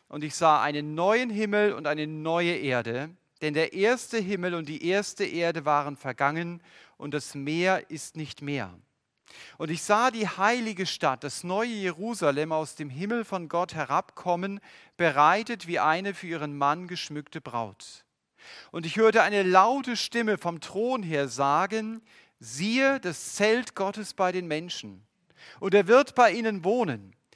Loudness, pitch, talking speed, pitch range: -27 LUFS, 170 Hz, 160 wpm, 150-205 Hz